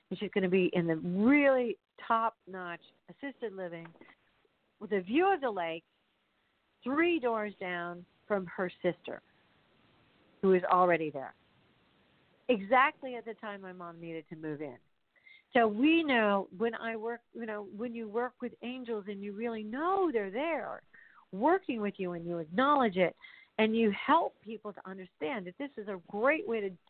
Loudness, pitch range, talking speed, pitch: -32 LUFS, 180-245 Hz, 170 wpm, 215 Hz